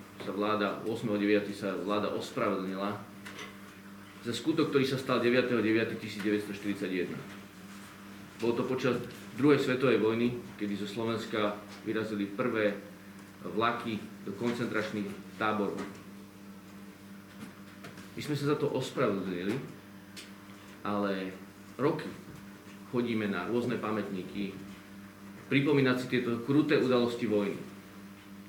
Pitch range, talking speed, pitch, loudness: 100-115 Hz, 95 wpm, 100 Hz, -32 LUFS